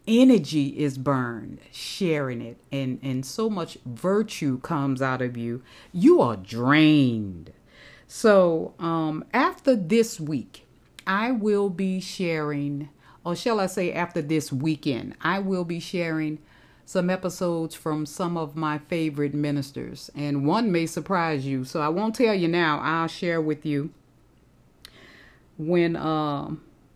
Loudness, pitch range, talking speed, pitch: -25 LUFS, 140-180 Hz, 140 wpm, 155 Hz